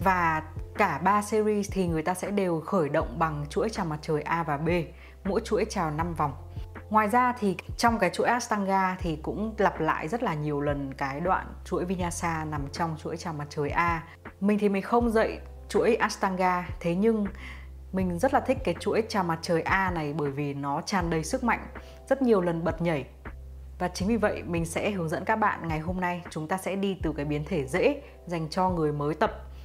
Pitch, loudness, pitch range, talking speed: 175 Hz, -28 LUFS, 150-200 Hz, 220 wpm